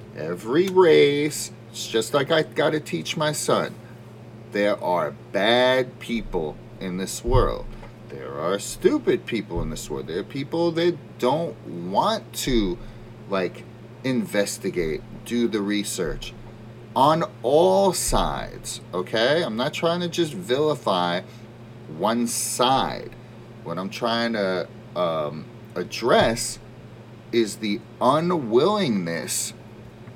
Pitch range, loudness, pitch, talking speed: 110-145 Hz, -23 LUFS, 115 Hz, 115 wpm